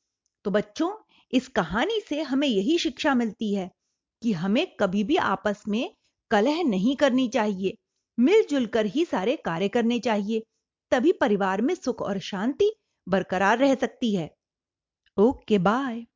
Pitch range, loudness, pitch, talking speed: 205-280 Hz, -25 LUFS, 235 Hz, 145 wpm